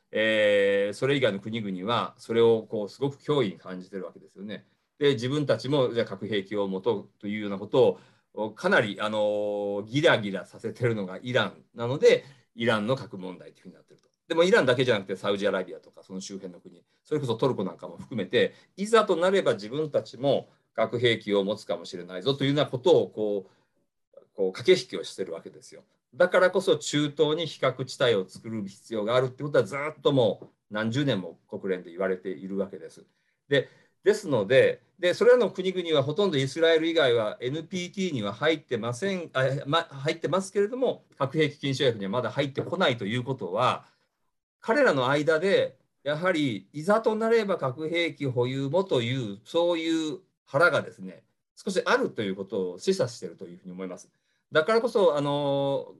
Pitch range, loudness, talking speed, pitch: 105-165 Hz, -26 LUFS, 395 characters per minute, 135 Hz